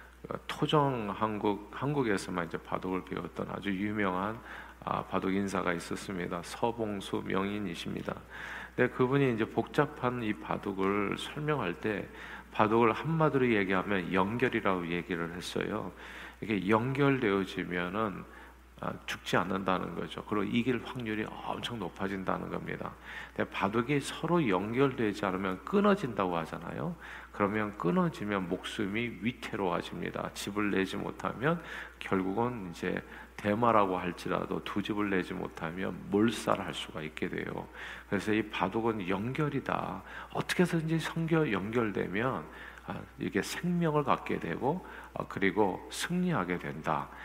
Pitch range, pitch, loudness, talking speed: 95-125 Hz, 105 Hz, -32 LUFS, 305 characters per minute